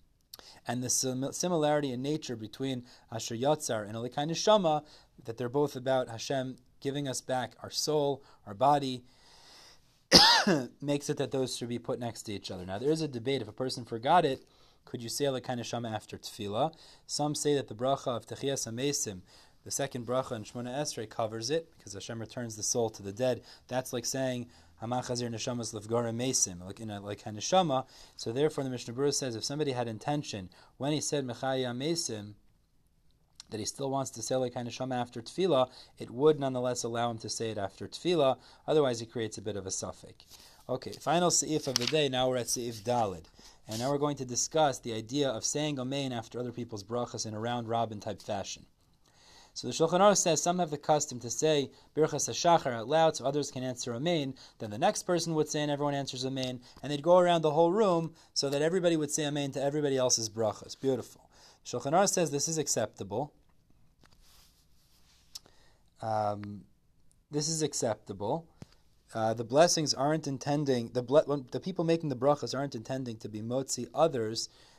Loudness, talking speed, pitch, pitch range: -31 LUFS, 190 wpm, 130 Hz, 115-145 Hz